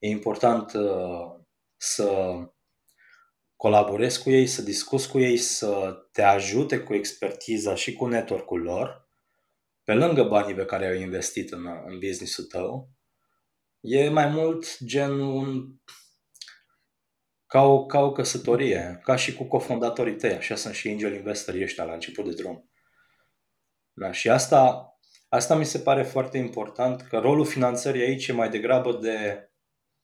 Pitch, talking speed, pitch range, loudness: 125 Hz, 140 wpm, 105-135 Hz, -25 LUFS